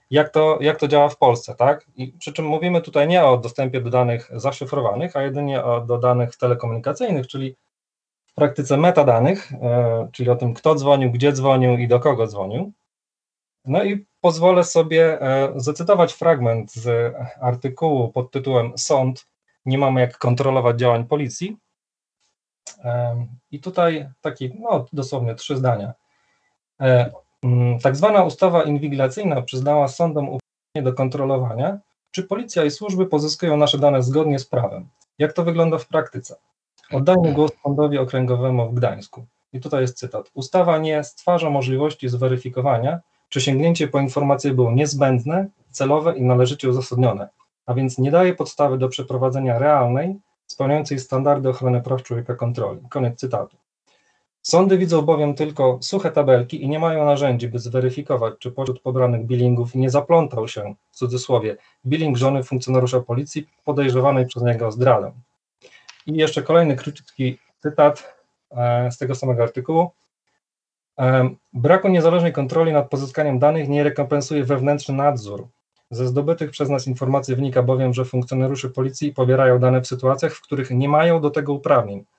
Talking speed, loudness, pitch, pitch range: 145 wpm, -19 LUFS, 135 Hz, 125-150 Hz